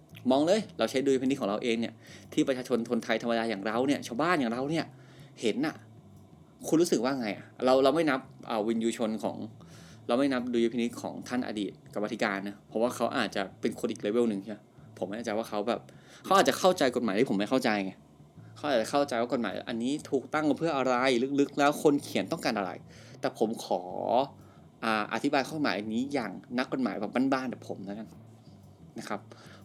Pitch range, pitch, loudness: 110-135 Hz, 120 Hz, -30 LUFS